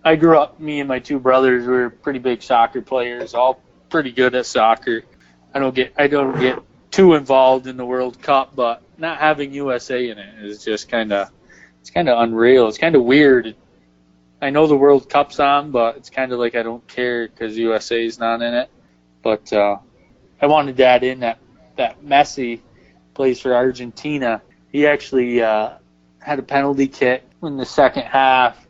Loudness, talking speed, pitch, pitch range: -17 LUFS, 190 wpm, 125 Hz, 115-140 Hz